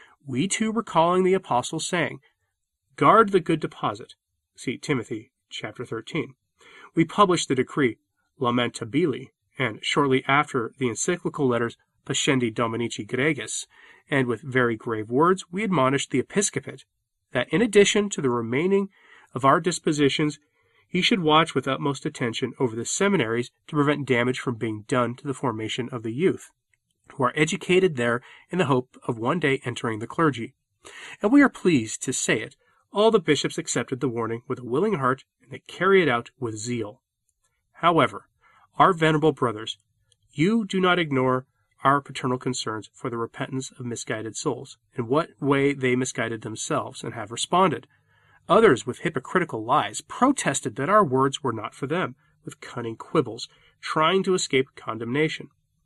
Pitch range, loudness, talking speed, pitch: 120-165 Hz, -24 LUFS, 160 wpm, 135 Hz